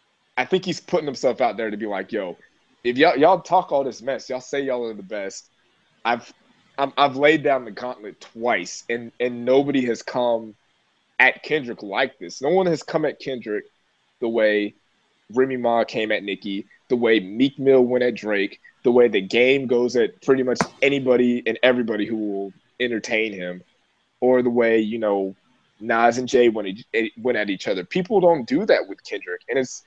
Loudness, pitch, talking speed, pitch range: -21 LUFS, 125 Hz, 195 wpm, 110-135 Hz